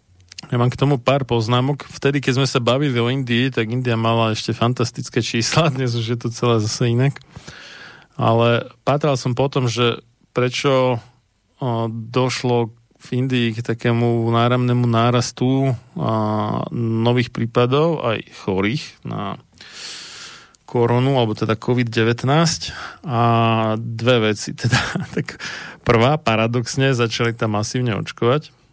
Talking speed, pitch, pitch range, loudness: 120 wpm, 120 Hz, 115-130 Hz, -19 LUFS